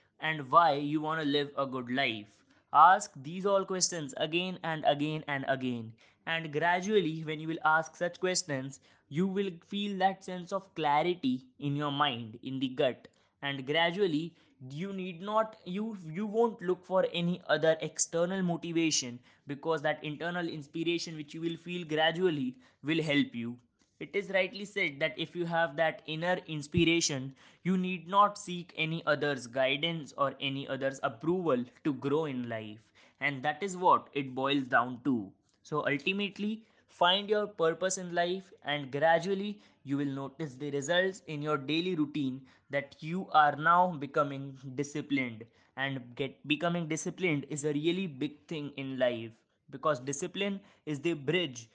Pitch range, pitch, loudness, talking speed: 140-175 Hz, 155 Hz, -32 LUFS, 160 wpm